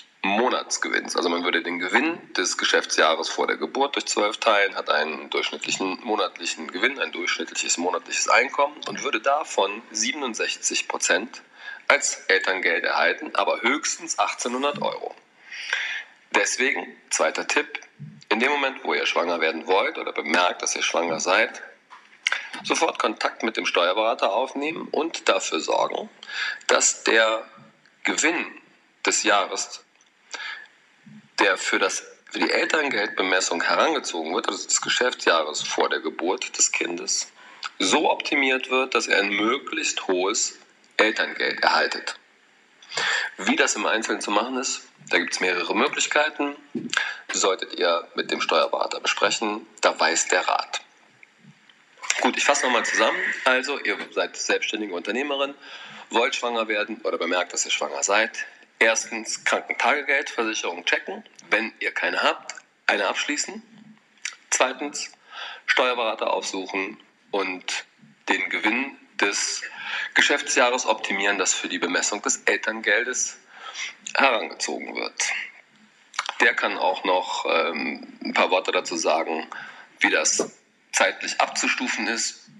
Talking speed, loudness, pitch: 125 wpm, -23 LUFS, 330 Hz